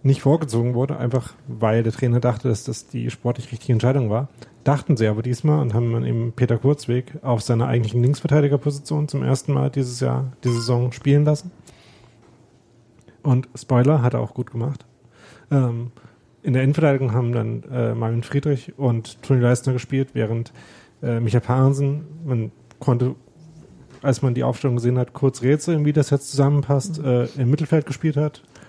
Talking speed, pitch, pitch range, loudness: 160 wpm, 125 Hz, 120-140 Hz, -21 LUFS